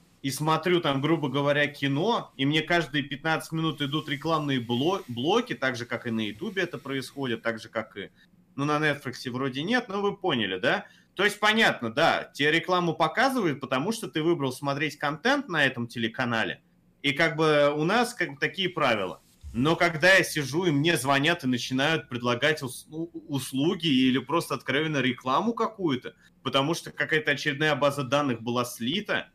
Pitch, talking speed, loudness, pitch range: 145 Hz, 175 wpm, -26 LUFS, 130-165 Hz